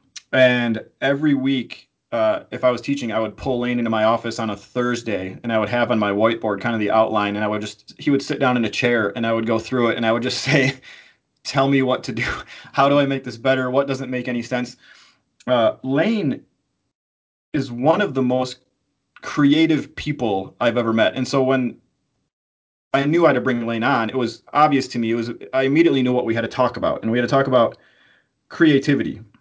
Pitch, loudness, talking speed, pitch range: 125 Hz, -20 LUFS, 230 wpm, 115-135 Hz